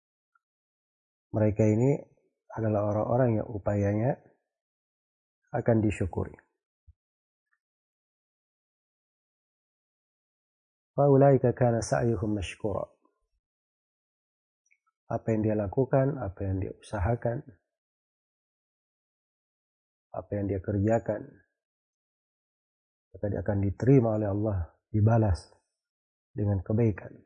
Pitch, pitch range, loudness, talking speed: 110 Hz, 100-120 Hz, -28 LUFS, 65 wpm